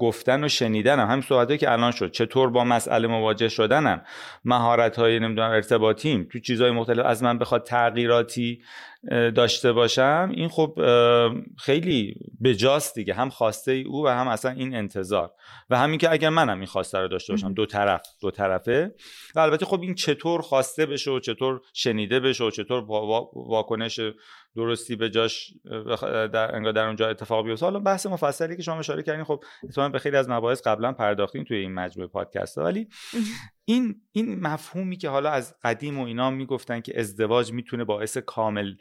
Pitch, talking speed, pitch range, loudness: 120 Hz, 175 wpm, 115-140 Hz, -24 LUFS